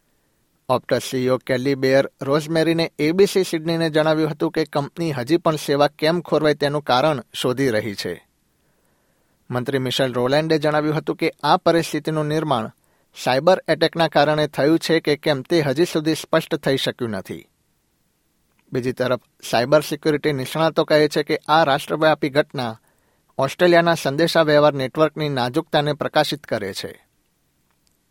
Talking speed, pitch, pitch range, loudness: 130 wpm, 150 Hz, 135-160 Hz, -20 LUFS